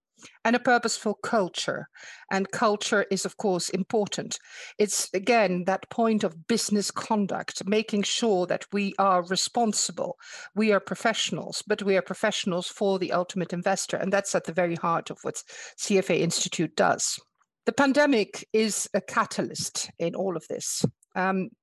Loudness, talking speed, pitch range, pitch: -26 LUFS, 155 wpm, 185-220 Hz, 200 Hz